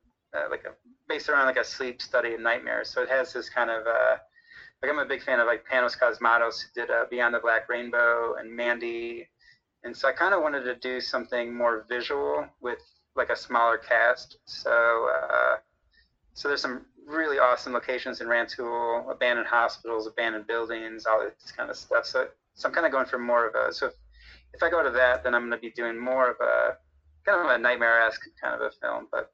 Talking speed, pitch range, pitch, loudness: 215 wpm, 115-130 Hz, 120 Hz, -26 LUFS